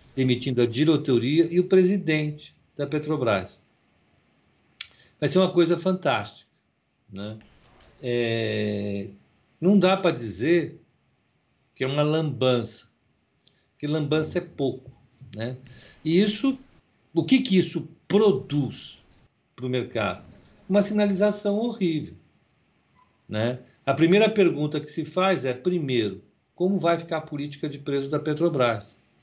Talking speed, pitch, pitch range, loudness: 120 wpm, 150 Hz, 125-180 Hz, -24 LUFS